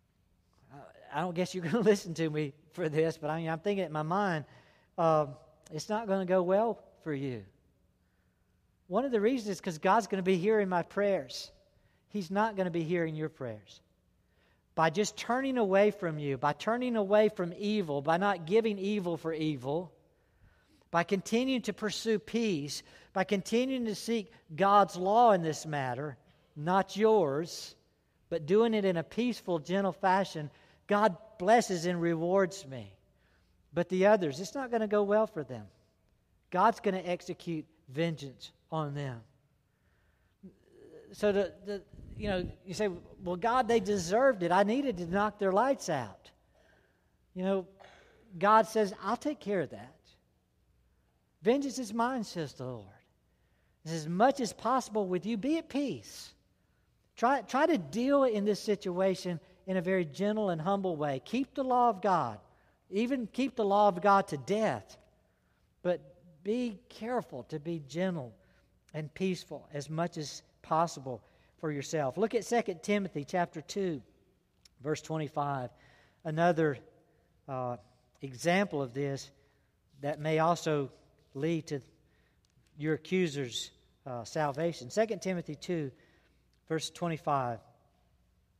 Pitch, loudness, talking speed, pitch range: 175 Hz, -32 LUFS, 150 wpm, 145-205 Hz